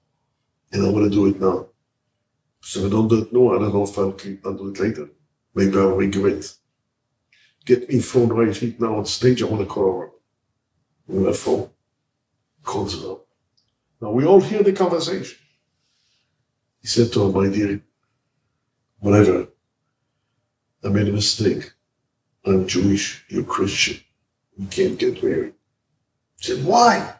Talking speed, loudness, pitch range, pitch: 150 wpm, -20 LUFS, 100-130 Hz, 115 Hz